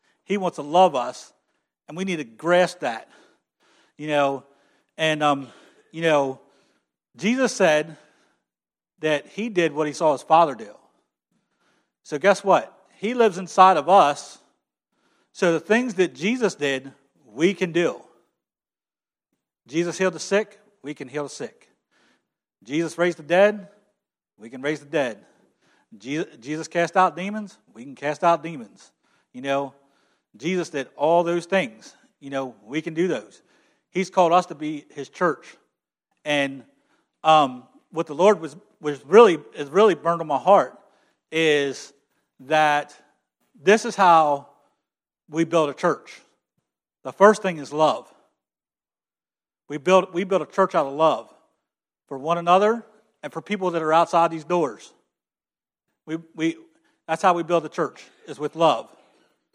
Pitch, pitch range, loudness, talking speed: 165 Hz, 145-190 Hz, -22 LUFS, 150 wpm